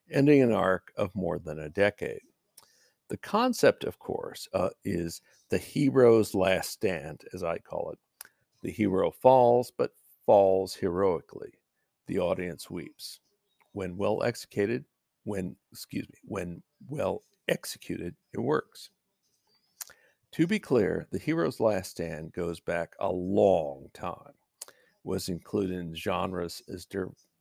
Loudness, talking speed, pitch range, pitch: -29 LUFS, 135 wpm, 90-125 Hz, 95 Hz